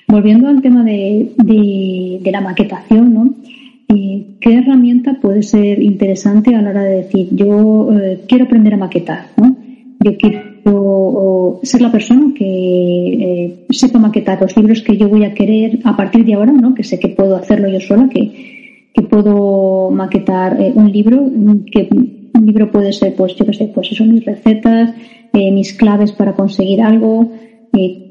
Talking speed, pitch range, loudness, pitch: 175 wpm, 200-235 Hz, -11 LUFS, 215 Hz